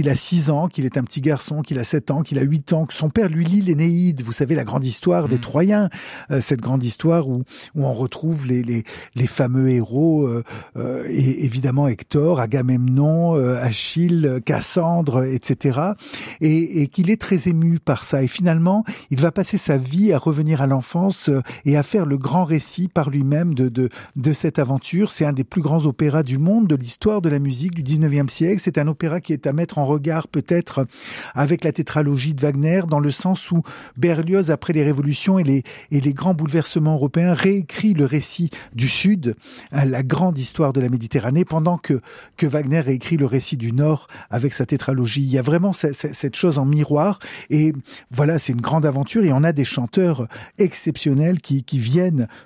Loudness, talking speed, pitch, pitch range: -19 LUFS, 200 wpm, 150 Hz, 135-170 Hz